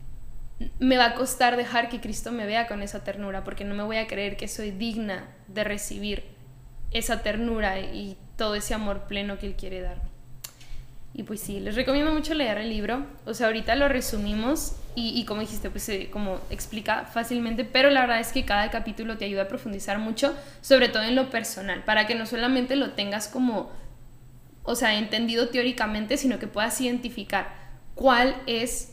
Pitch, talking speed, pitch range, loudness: 220 Hz, 190 wpm, 200-245 Hz, -26 LUFS